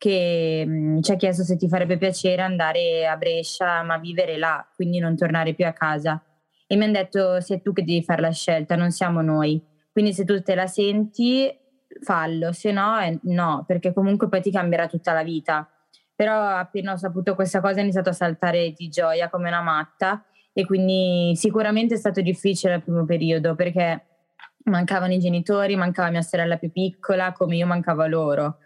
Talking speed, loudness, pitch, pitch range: 185 wpm, -22 LUFS, 180 Hz, 165-195 Hz